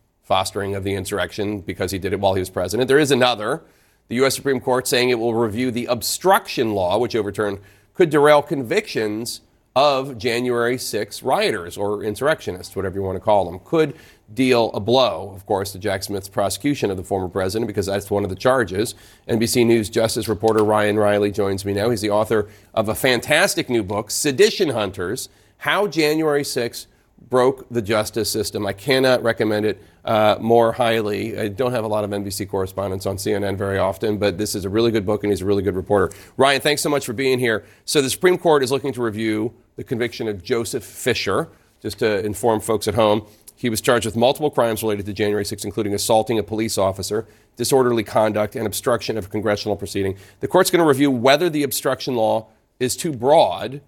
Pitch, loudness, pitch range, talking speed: 110 Hz, -20 LUFS, 100-125 Hz, 205 wpm